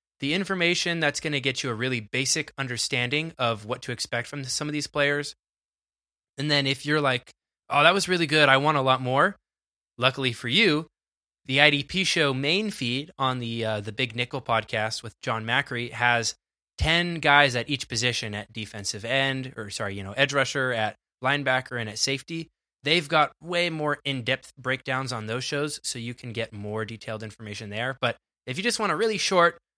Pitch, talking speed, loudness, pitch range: 130 Hz, 200 wpm, -25 LUFS, 120-145 Hz